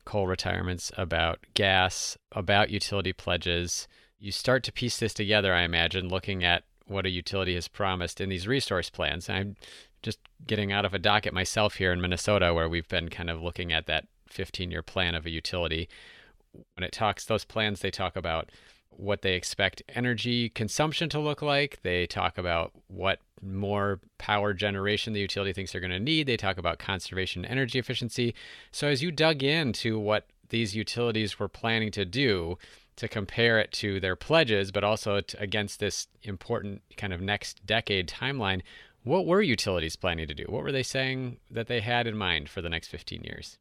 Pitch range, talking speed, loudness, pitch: 90-110 Hz, 190 wpm, -28 LUFS, 100 Hz